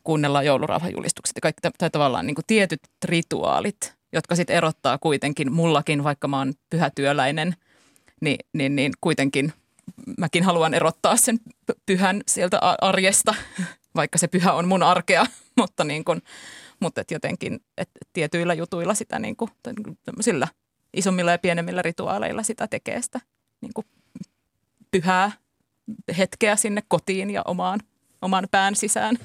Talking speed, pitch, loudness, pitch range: 140 wpm, 180 Hz, -23 LUFS, 160-210 Hz